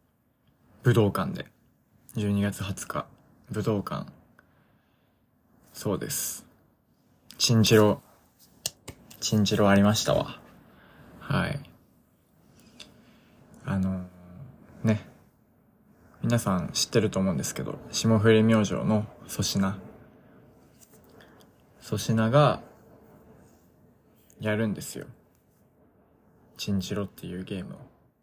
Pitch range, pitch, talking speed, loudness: 100-110 Hz, 105 Hz, 160 characters per minute, -27 LUFS